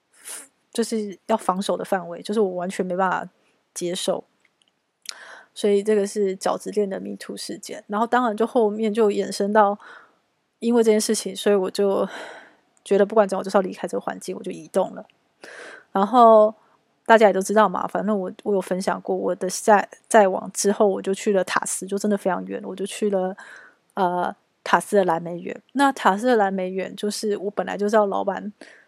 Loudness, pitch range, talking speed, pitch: -22 LUFS, 190-215 Hz, 285 characters per minute, 205 Hz